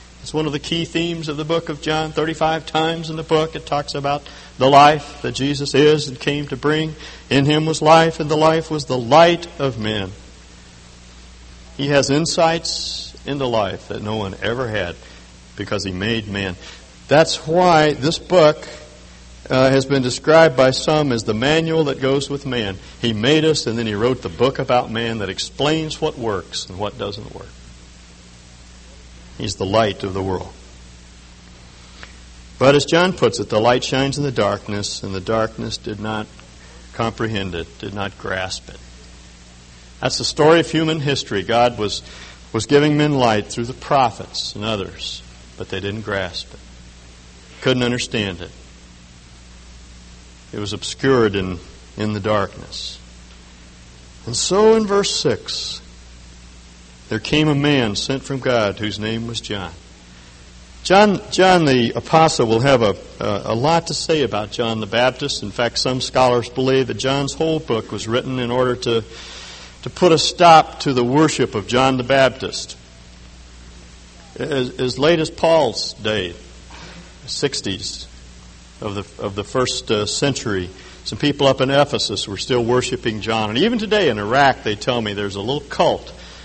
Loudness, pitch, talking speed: -18 LUFS, 115 Hz, 170 wpm